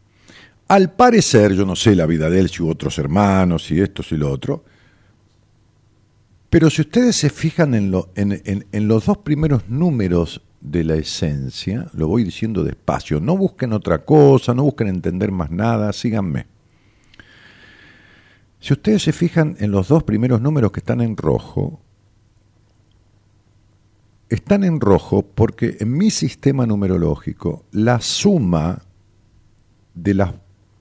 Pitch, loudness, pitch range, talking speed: 105 Hz, -17 LUFS, 100-125 Hz, 145 wpm